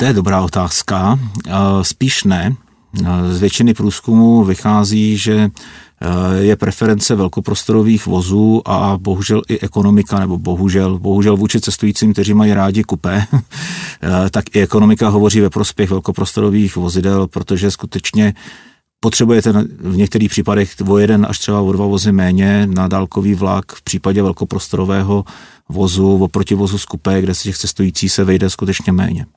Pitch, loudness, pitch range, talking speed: 100 Hz, -14 LUFS, 95-105 Hz, 140 wpm